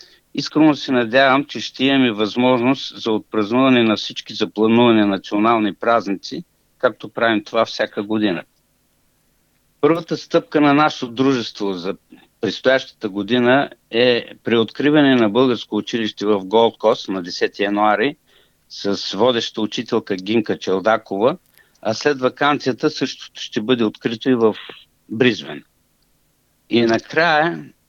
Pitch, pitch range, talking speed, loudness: 115 Hz, 110-130 Hz, 120 wpm, -18 LUFS